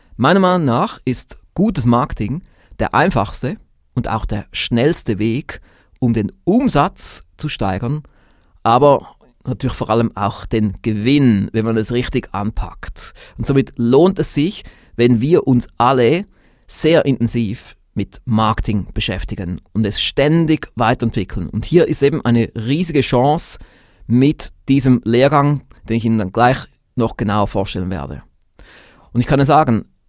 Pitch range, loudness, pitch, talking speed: 110-140 Hz, -17 LUFS, 120 Hz, 145 wpm